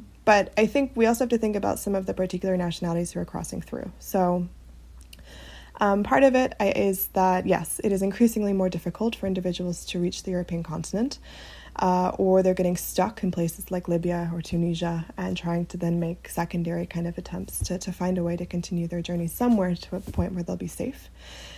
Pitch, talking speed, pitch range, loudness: 180 Hz, 210 wpm, 170-195 Hz, -26 LUFS